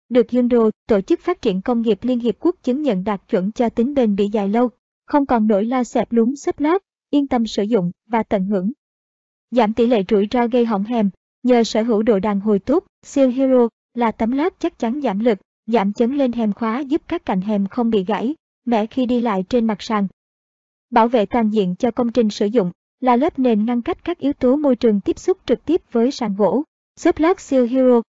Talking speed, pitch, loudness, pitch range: 235 wpm, 240 Hz, -19 LUFS, 220-260 Hz